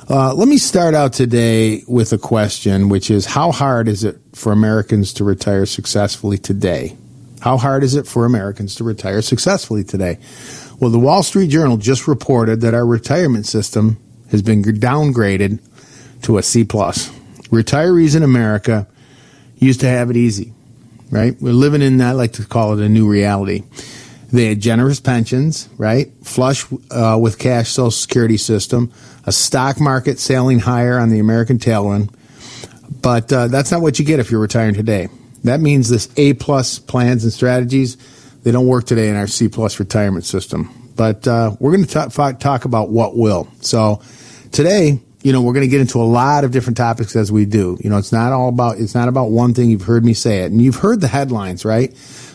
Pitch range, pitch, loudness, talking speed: 110-130 Hz, 120 Hz, -15 LUFS, 195 wpm